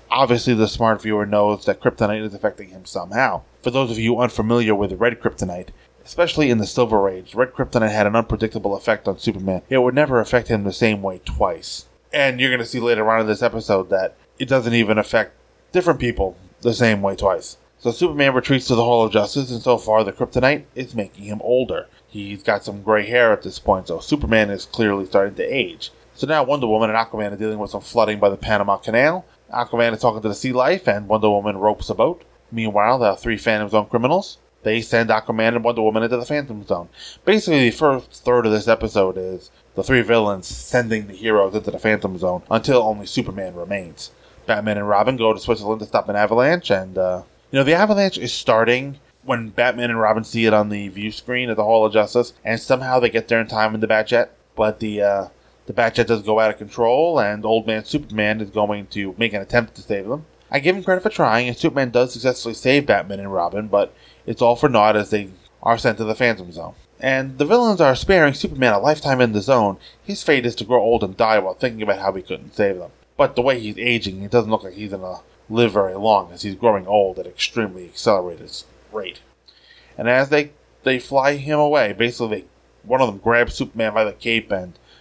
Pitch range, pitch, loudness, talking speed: 105-125 Hz, 110 Hz, -19 LUFS, 225 wpm